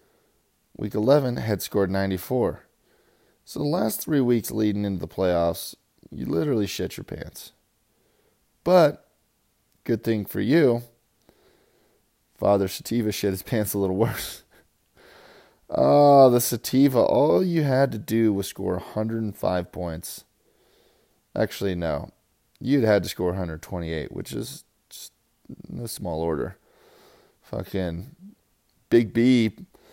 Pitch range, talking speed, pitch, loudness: 95-120 Hz, 120 wpm, 105 Hz, -24 LUFS